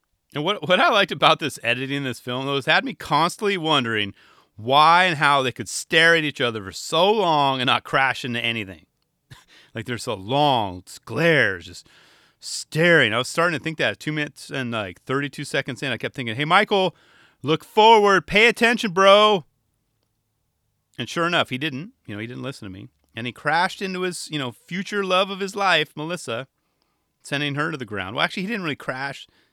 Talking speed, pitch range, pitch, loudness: 205 wpm, 120-170 Hz, 145 Hz, -20 LUFS